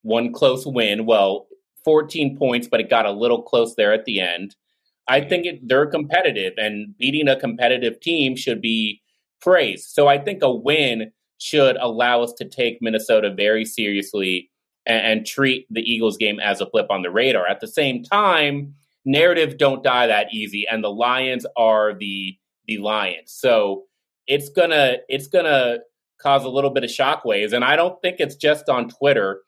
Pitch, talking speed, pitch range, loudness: 130 Hz, 180 wpm, 110-145 Hz, -19 LUFS